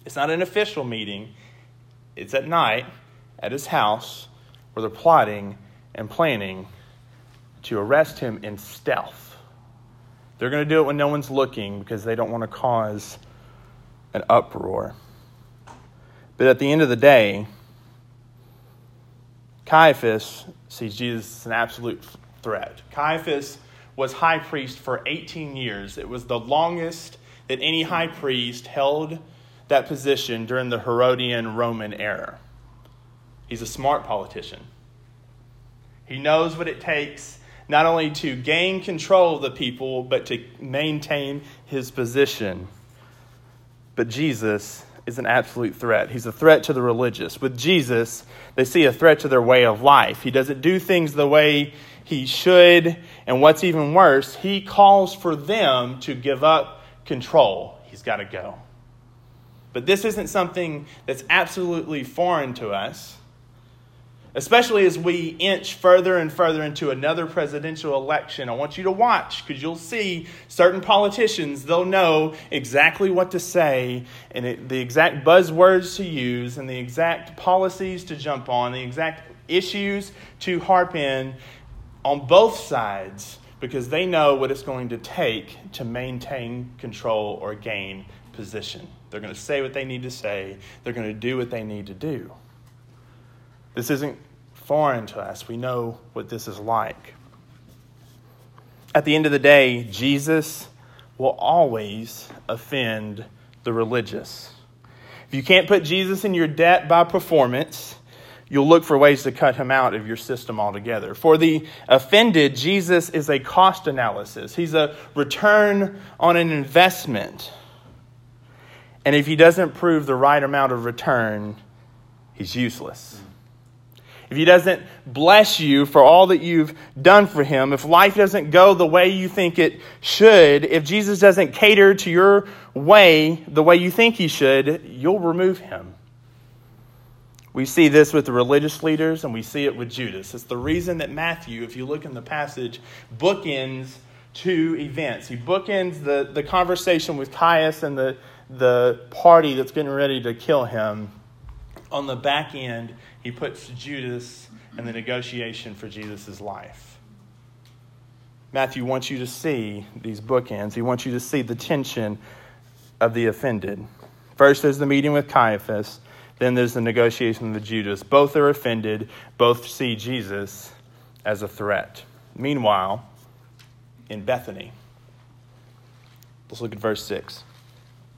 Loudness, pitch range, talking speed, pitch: -19 LUFS, 120-155 Hz, 150 wpm, 130 Hz